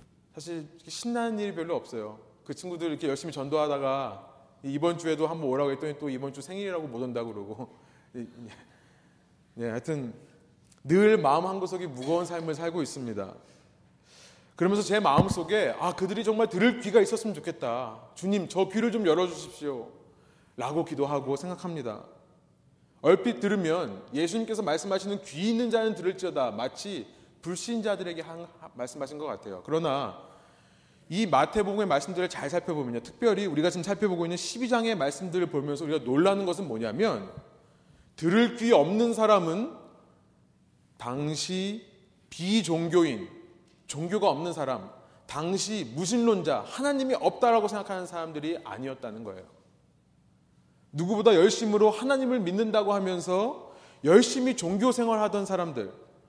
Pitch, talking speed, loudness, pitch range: 175 Hz, 325 characters per minute, -28 LUFS, 145-205 Hz